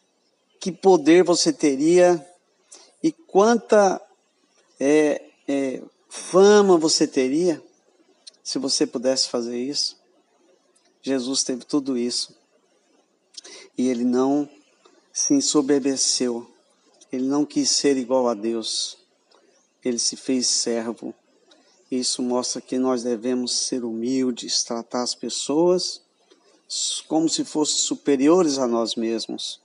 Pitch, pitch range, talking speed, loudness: 135 Hz, 125-165 Hz, 105 wpm, -21 LUFS